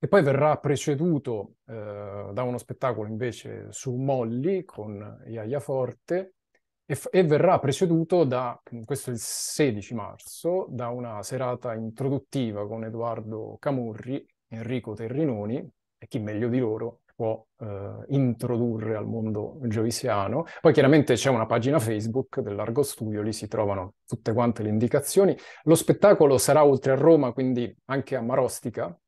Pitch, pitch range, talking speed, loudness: 125 Hz, 110-140 Hz, 145 wpm, -25 LUFS